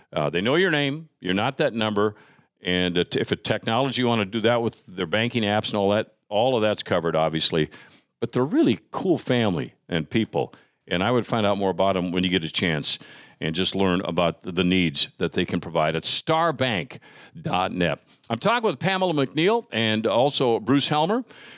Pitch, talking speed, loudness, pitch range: 110 Hz, 195 wpm, -23 LUFS, 90-135 Hz